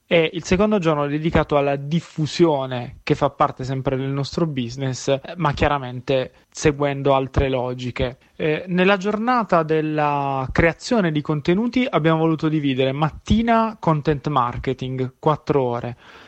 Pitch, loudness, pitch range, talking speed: 150 Hz, -21 LUFS, 135-165 Hz, 130 wpm